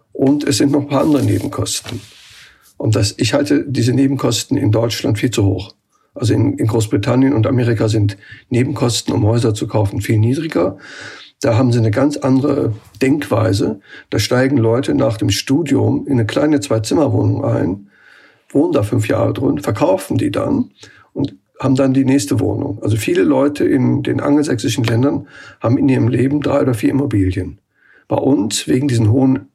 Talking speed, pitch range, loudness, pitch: 175 wpm, 110-135 Hz, -16 LUFS, 125 Hz